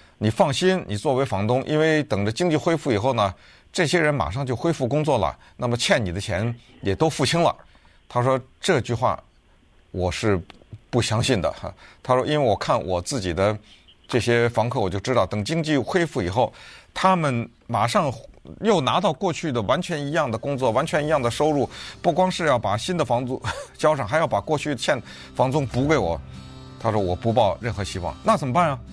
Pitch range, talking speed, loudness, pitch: 105-150 Hz, 285 characters per minute, -23 LUFS, 125 Hz